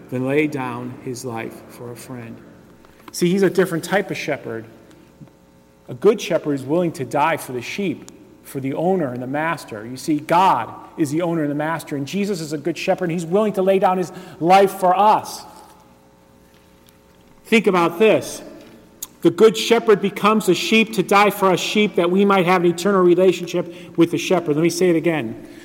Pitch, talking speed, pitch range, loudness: 165 Hz, 200 wpm, 125-185 Hz, -18 LUFS